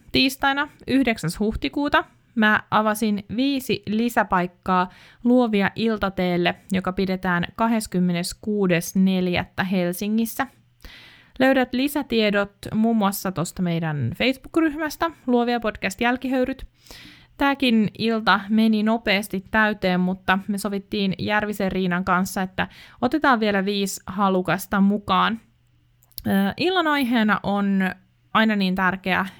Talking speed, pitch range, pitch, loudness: 95 wpm, 185-230 Hz, 205 Hz, -22 LUFS